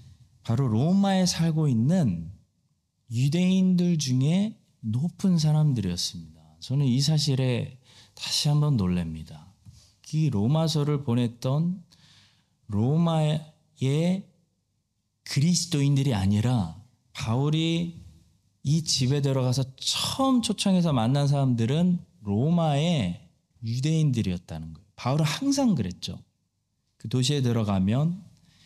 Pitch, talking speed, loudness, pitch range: 135 Hz, 235 characters per minute, -25 LUFS, 110-160 Hz